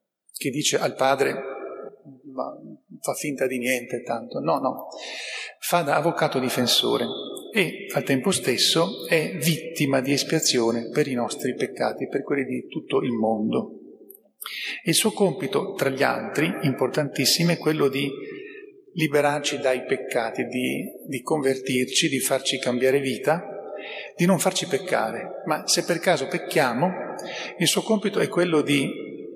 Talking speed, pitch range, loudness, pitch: 140 wpm, 130-175 Hz, -24 LUFS, 145 Hz